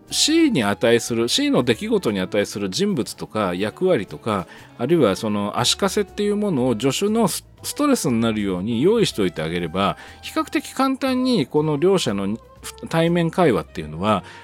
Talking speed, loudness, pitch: 345 characters per minute, -20 LUFS, 165 Hz